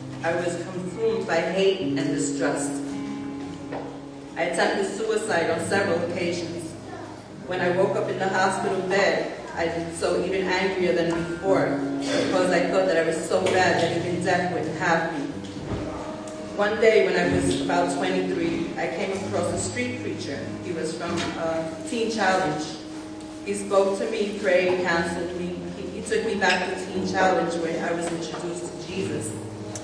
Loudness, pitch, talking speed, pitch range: -25 LUFS, 170 Hz, 165 wpm, 160-185 Hz